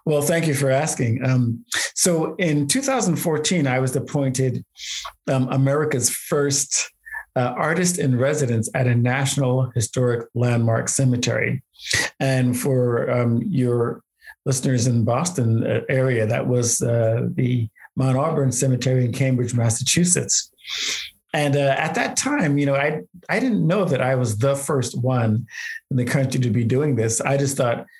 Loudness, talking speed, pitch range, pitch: -21 LUFS, 150 wpm, 125-145 Hz, 130 Hz